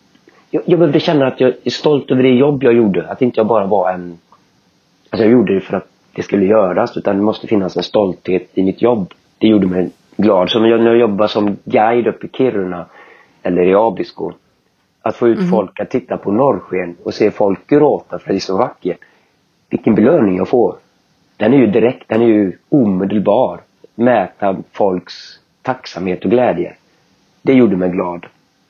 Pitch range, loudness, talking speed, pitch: 95-125 Hz, -14 LUFS, 190 wpm, 110 Hz